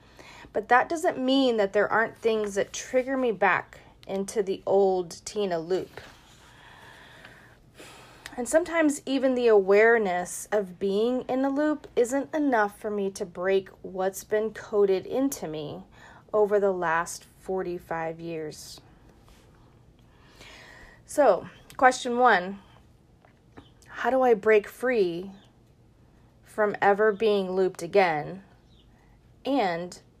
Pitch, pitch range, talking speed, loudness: 205 Hz, 185-245 Hz, 115 wpm, -25 LUFS